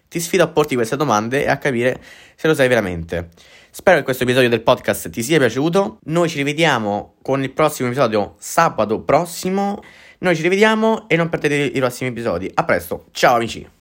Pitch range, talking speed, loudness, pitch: 115-170 Hz, 190 wpm, -18 LUFS, 140 Hz